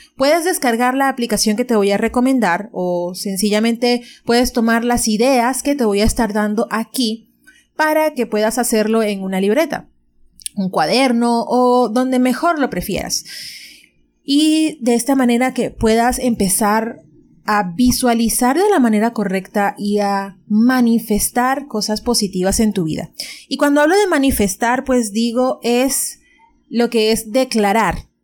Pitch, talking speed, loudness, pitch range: 235 Hz, 145 wpm, -16 LUFS, 210-255 Hz